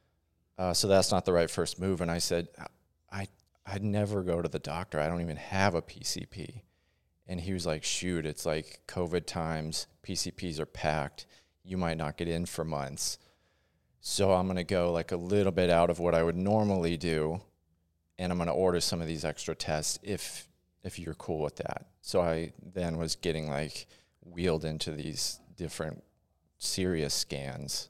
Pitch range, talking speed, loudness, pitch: 80-90 Hz, 185 wpm, -32 LUFS, 85 Hz